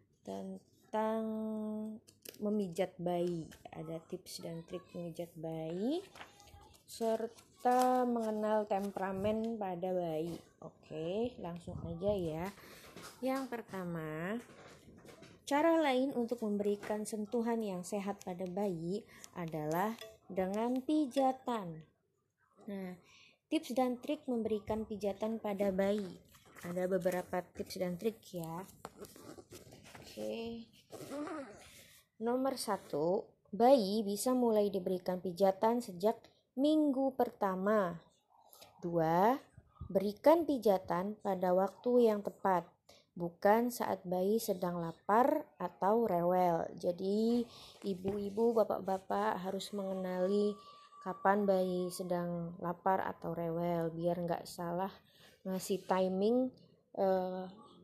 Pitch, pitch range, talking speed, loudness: 200 Hz, 180-225 Hz, 90 wpm, -36 LUFS